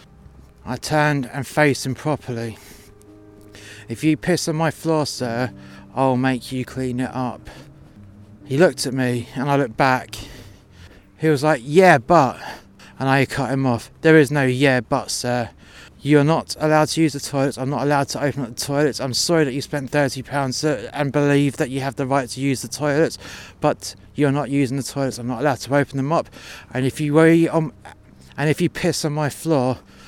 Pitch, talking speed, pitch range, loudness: 135 Hz, 200 wpm, 120-150 Hz, -20 LUFS